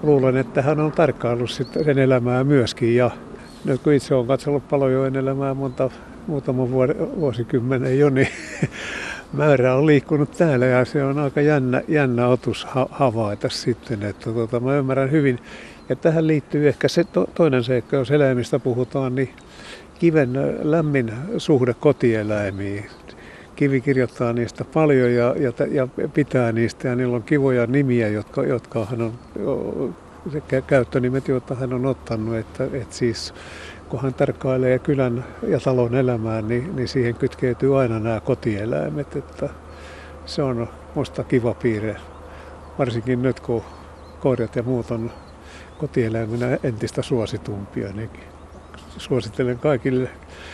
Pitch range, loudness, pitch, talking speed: 115-140 Hz, -21 LUFS, 130 Hz, 130 wpm